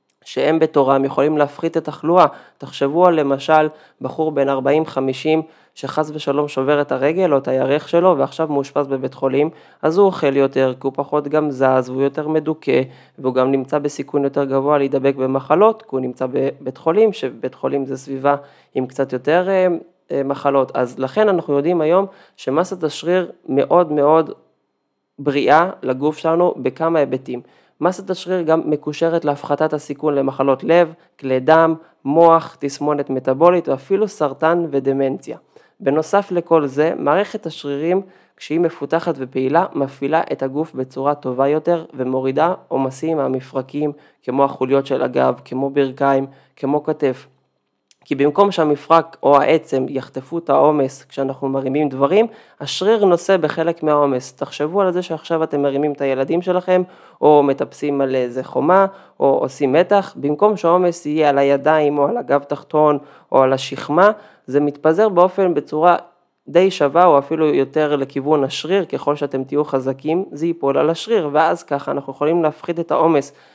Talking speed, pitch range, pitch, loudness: 150 wpm, 135-165 Hz, 145 Hz, -18 LUFS